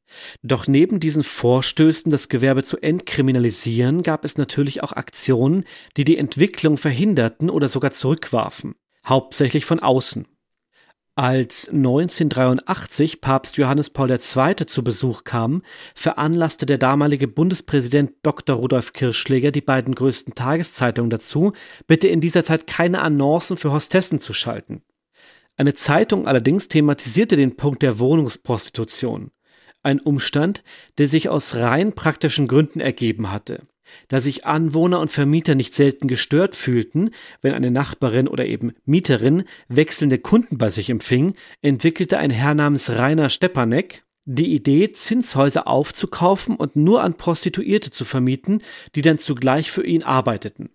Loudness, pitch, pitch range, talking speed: -19 LUFS, 145 Hz, 130-160 Hz, 135 wpm